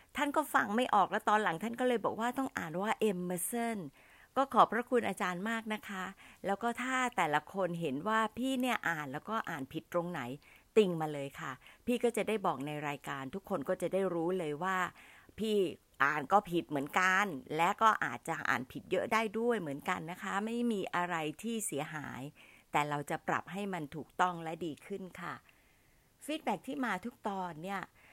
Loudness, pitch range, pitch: -34 LUFS, 165-225 Hz, 190 Hz